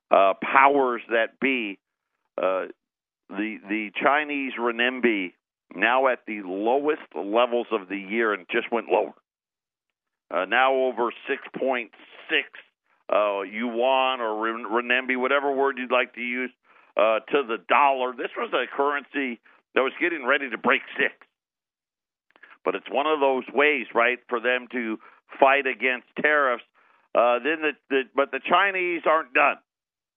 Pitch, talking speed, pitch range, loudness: 125 Hz, 145 wpm, 115-140 Hz, -24 LUFS